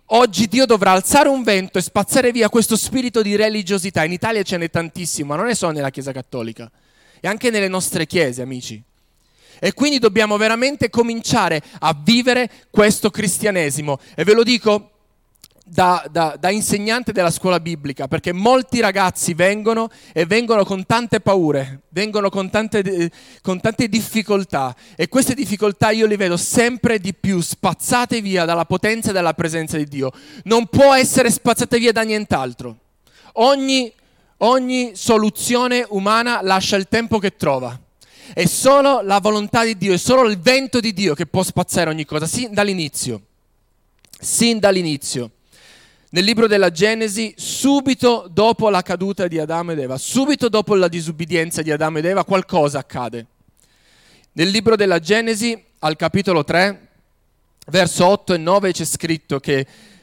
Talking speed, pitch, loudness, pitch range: 160 wpm, 195 Hz, -17 LUFS, 165-225 Hz